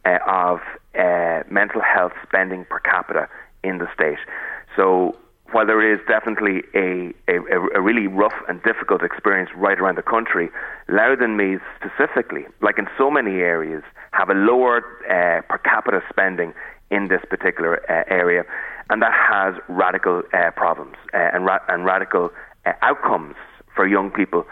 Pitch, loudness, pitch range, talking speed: 95 Hz, -19 LUFS, 90-110 Hz, 155 wpm